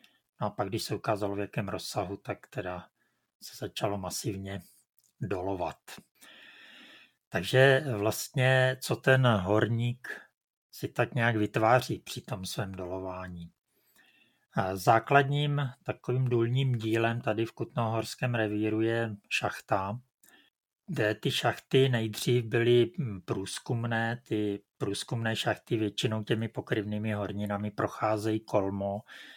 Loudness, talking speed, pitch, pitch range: -30 LUFS, 110 wpm, 115 Hz, 105-125 Hz